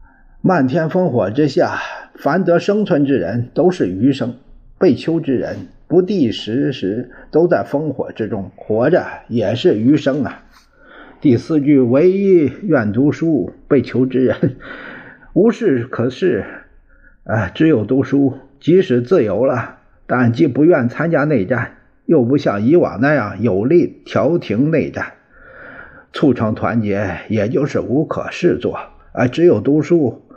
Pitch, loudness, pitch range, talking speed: 140 Hz, -16 LUFS, 125-170 Hz, 200 characters per minute